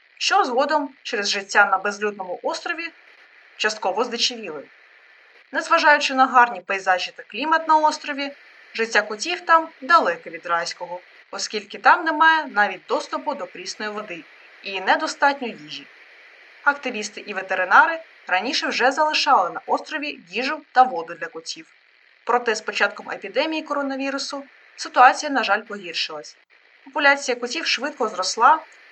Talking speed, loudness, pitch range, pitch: 125 wpm, -21 LUFS, 205-305 Hz, 255 Hz